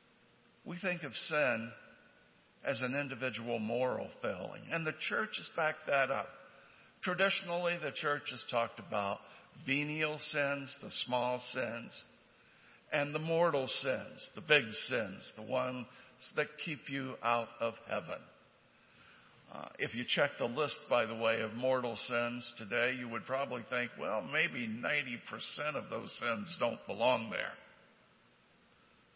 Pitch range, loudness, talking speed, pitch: 120-150 Hz, -36 LUFS, 140 wpm, 130 Hz